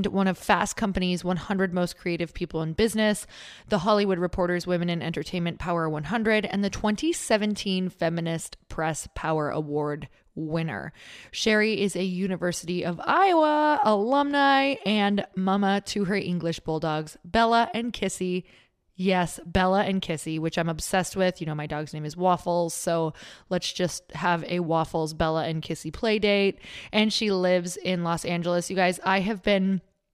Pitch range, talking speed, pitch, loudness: 165-205 Hz, 155 wpm, 180 Hz, -26 LUFS